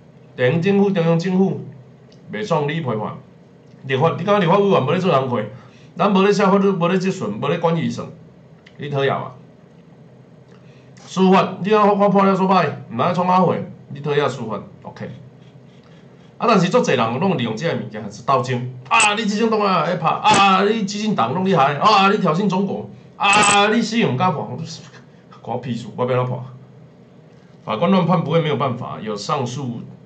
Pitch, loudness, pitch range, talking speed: 175 Hz, -18 LUFS, 145-200 Hz, 260 characters per minute